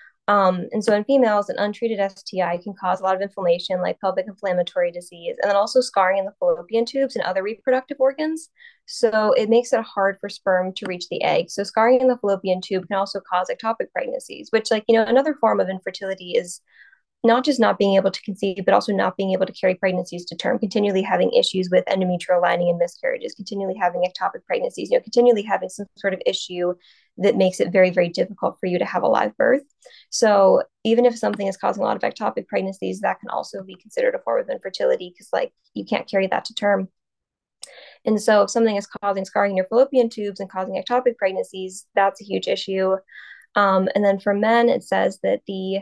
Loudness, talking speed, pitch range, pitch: -21 LUFS, 220 wpm, 190-235 Hz, 200 Hz